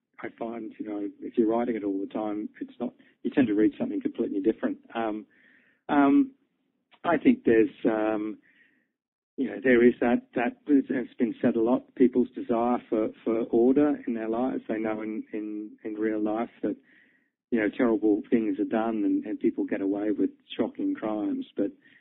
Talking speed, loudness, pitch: 185 wpm, -27 LUFS, 120 Hz